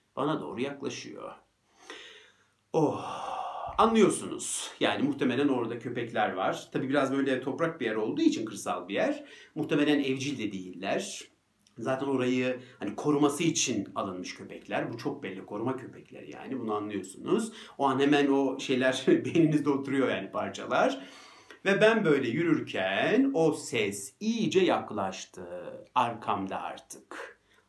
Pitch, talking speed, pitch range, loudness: 145 Hz, 130 wpm, 130-215 Hz, -29 LUFS